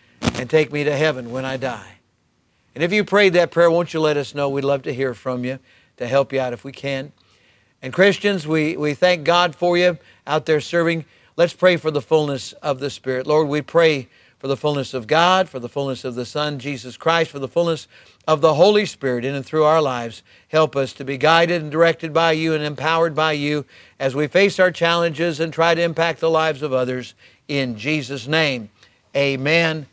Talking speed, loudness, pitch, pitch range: 220 wpm, -19 LUFS, 150 Hz, 130-165 Hz